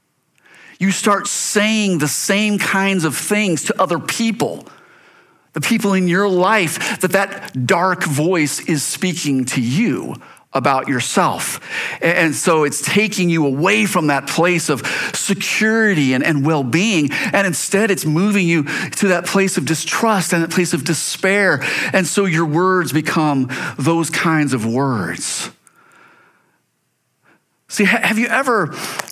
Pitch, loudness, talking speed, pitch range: 180 Hz, -16 LUFS, 140 wpm, 155-205 Hz